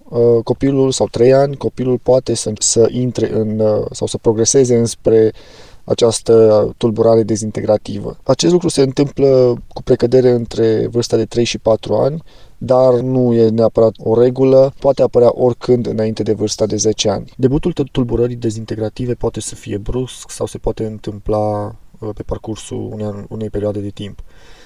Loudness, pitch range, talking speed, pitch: -15 LUFS, 110-125 Hz, 150 wpm, 115 Hz